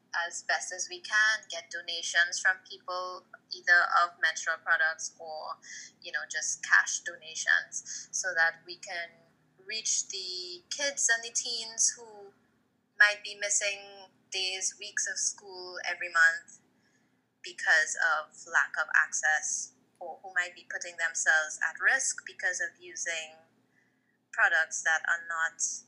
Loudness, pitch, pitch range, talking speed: -29 LUFS, 185 Hz, 170-220 Hz, 135 wpm